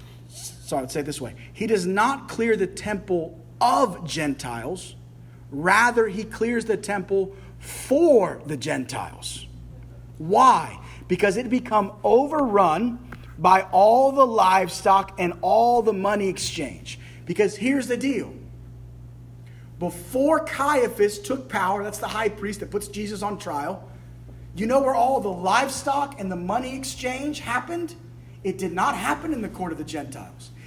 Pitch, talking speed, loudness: 190 Hz, 145 wpm, -23 LUFS